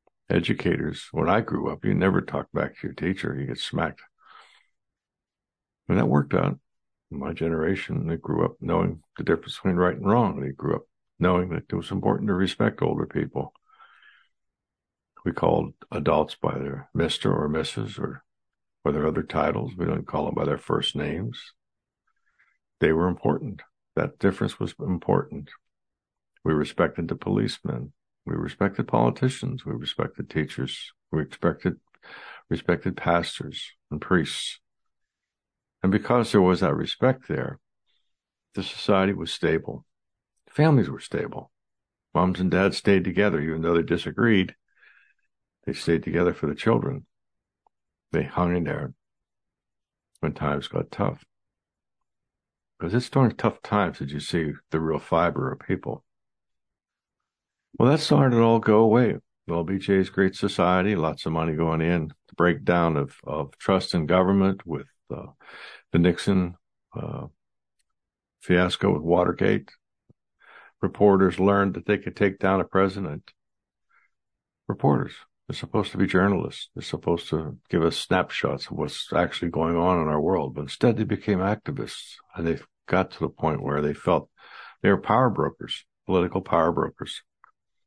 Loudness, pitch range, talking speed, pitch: -25 LUFS, 85-100 Hz, 150 wpm, 90 Hz